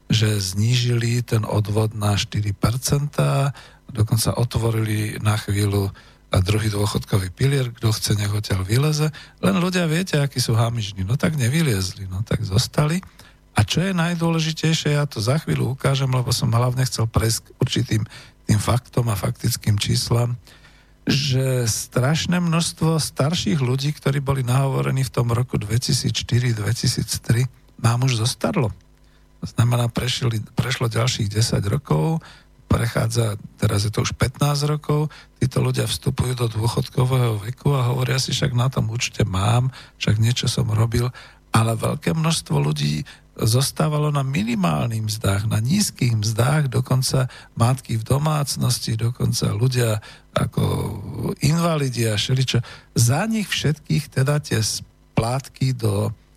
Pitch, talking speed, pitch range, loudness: 125 Hz, 135 wpm, 115-140 Hz, -21 LUFS